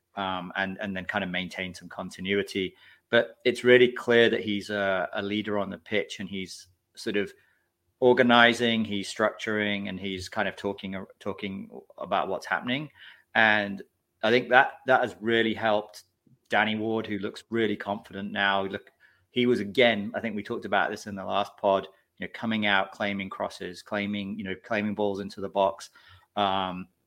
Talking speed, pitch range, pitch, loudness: 180 wpm, 95-110 Hz, 100 Hz, -27 LUFS